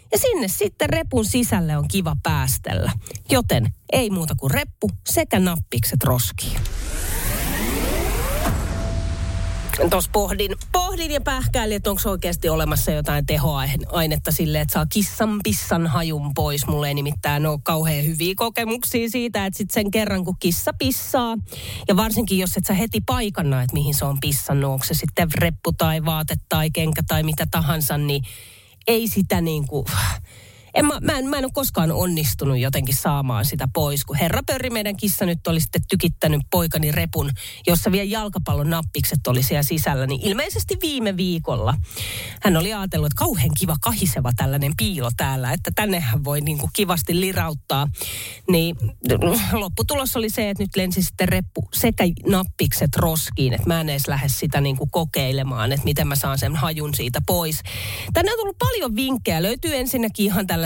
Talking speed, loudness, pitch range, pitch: 165 wpm, -21 LUFS, 135-200 Hz, 155 Hz